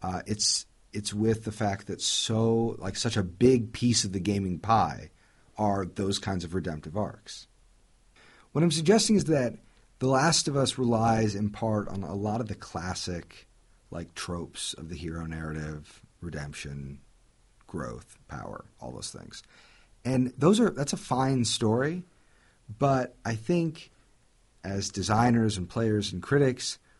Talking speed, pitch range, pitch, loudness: 155 wpm, 95-125 Hz, 110 Hz, -28 LUFS